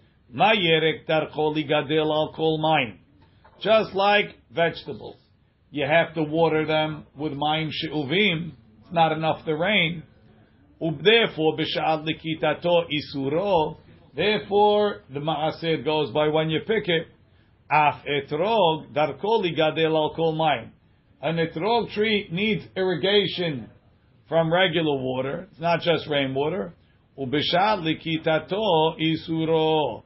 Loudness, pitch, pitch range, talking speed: -23 LUFS, 155 Hz, 150-170 Hz, 110 wpm